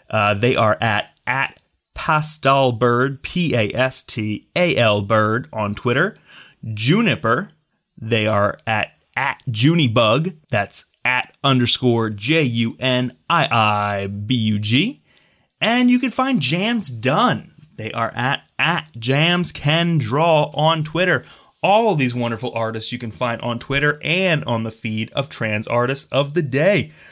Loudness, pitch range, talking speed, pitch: -18 LUFS, 115-160 Hz, 120 wpm, 125 Hz